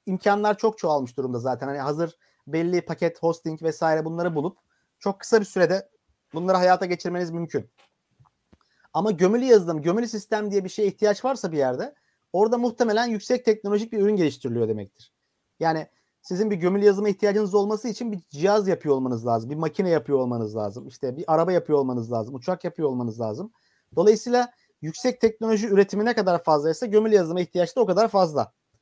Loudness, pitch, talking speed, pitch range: -24 LUFS, 180 Hz, 175 wpm, 155-210 Hz